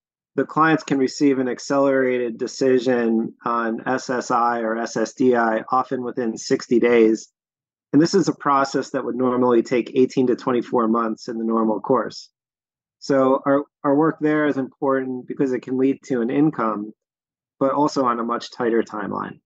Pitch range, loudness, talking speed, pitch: 115-135 Hz, -21 LUFS, 165 wpm, 130 Hz